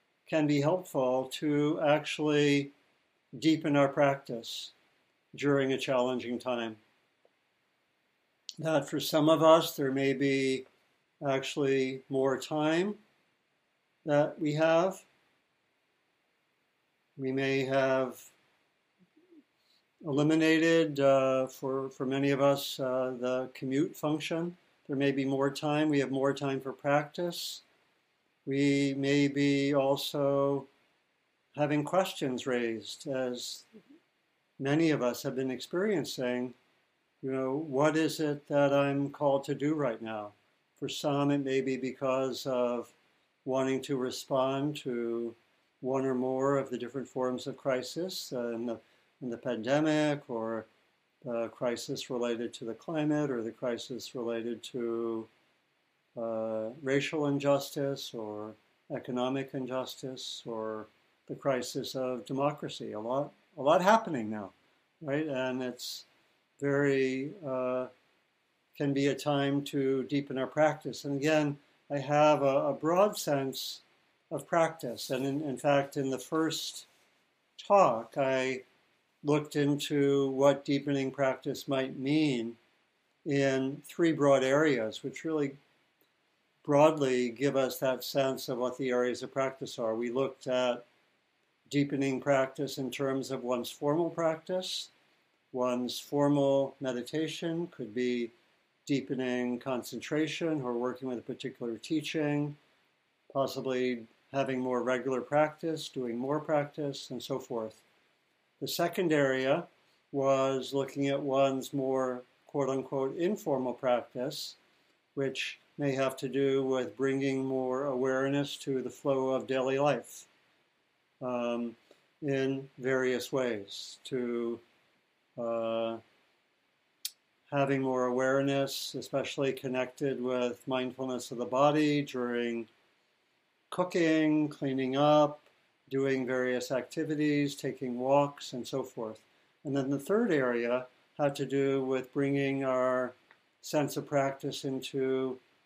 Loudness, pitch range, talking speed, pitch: -31 LUFS, 125-145 Hz, 120 wpm, 135 Hz